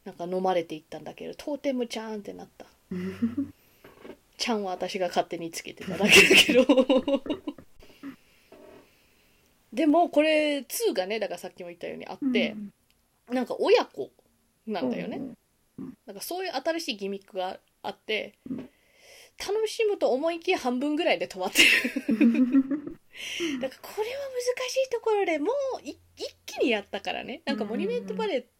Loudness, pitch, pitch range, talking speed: -25 LUFS, 265 Hz, 210-340 Hz, 310 characters per minute